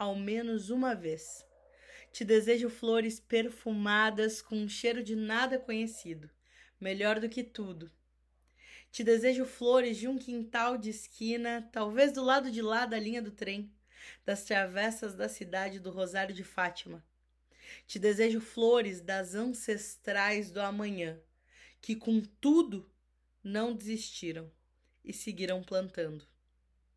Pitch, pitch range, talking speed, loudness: 215 Hz, 190-230 Hz, 130 wpm, -33 LUFS